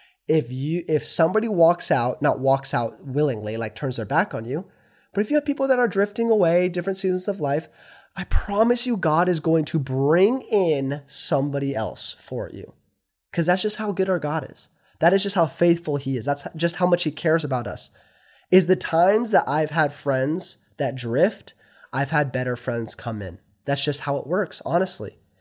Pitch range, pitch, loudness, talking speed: 135-185 Hz, 155 Hz, -22 LUFS, 205 wpm